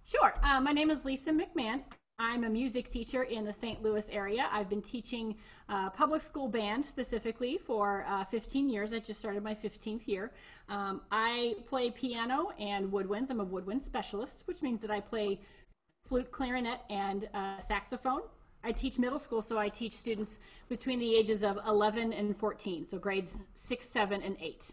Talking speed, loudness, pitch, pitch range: 180 wpm, -35 LUFS, 225 Hz, 205-250 Hz